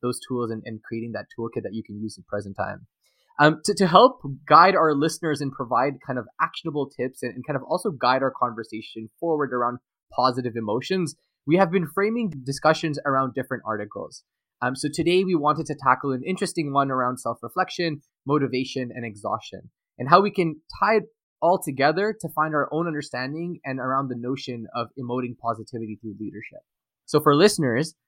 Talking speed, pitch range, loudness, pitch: 185 wpm, 125-160 Hz, -24 LUFS, 135 Hz